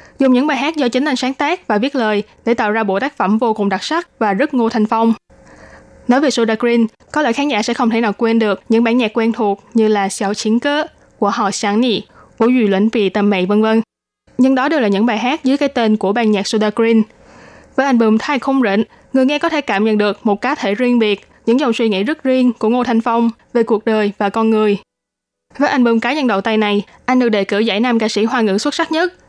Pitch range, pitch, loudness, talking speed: 210-255 Hz, 230 Hz, -15 LUFS, 270 wpm